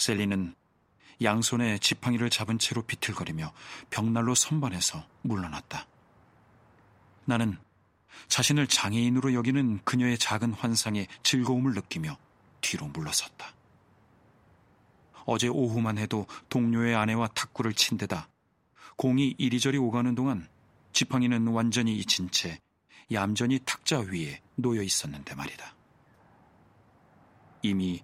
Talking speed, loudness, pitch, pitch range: 260 characters per minute, -28 LUFS, 115 Hz, 100-125 Hz